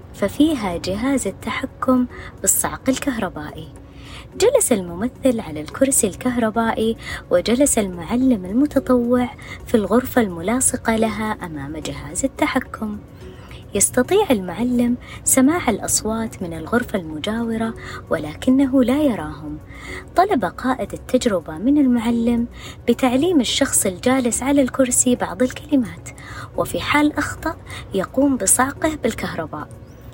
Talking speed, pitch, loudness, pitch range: 95 wpm, 245 Hz, -19 LUFS, 200-265 Hz